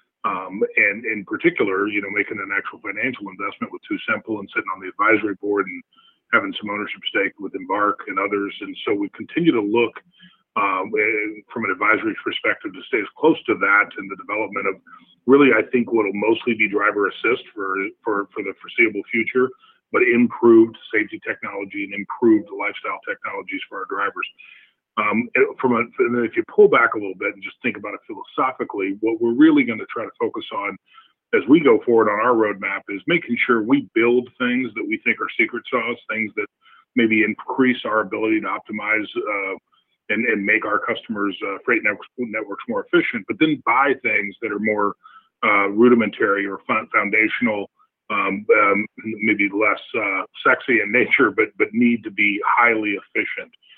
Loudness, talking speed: -20 LUFS, 185 wpm